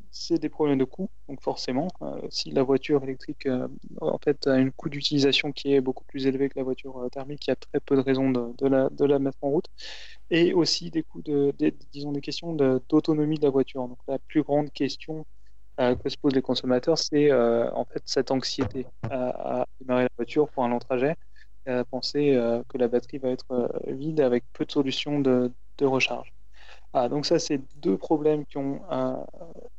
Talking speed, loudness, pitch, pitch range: 225 wpm, -26 LUFS, 135 Hz, 130-145 Hz